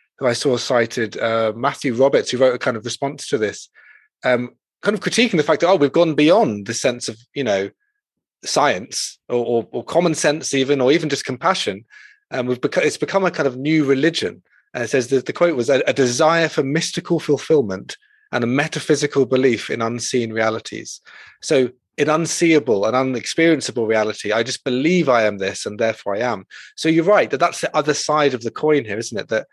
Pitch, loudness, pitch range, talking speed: 140 Hz, -19 LUFS, 120-160 Hz, 210 wpm